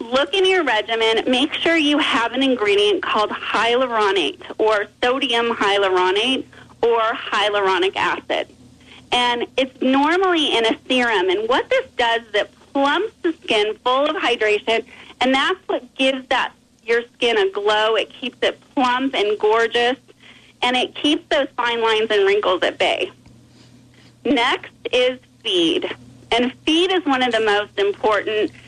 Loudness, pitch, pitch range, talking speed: -19 LUFS, 260 Hz, 230-360 Hz, 150 wpm